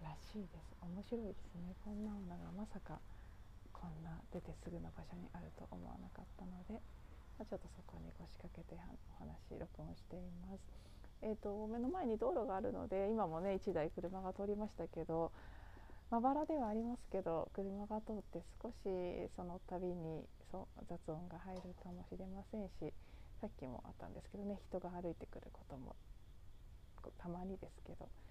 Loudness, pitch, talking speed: -47 LUFS, 175 Hz, 340 characters per minute